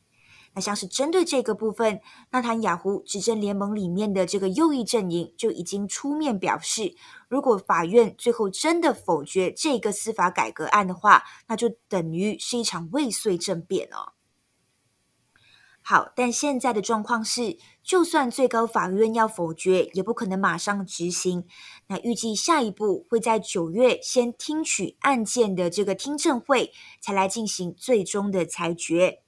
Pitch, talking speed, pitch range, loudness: 215 Hz, 245 characters per minute, 190-245 Hz, -24 LUFS